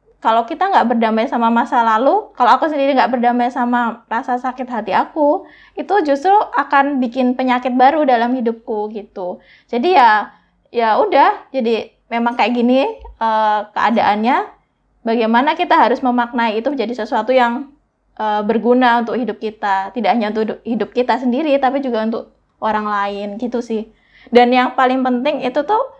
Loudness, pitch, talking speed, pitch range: -16 LUFS, 245 Hz, 150 wpm, 225-270 Hz